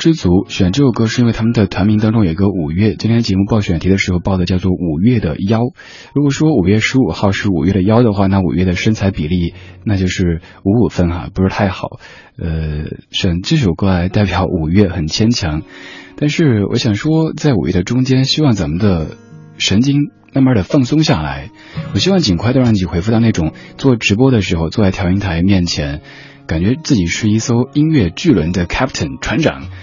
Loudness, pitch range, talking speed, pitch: -14 LUFS, 90-120 Hz, 320 characters per minute, 100 Hz